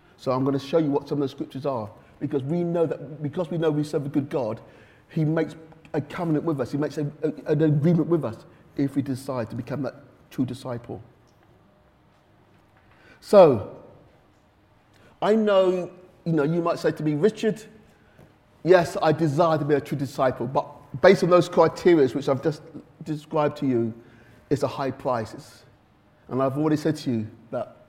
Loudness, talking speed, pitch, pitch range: -24 LUFS, 190 wpm, 150 Hz, 135-160 Hz